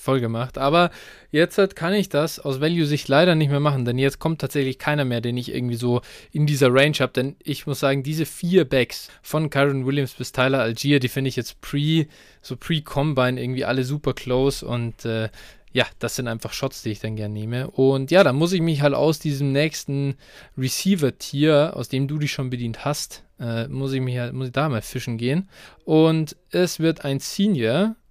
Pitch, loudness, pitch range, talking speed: 140 Hz, -22 LUFS, 125-155 Hz, 210 wpm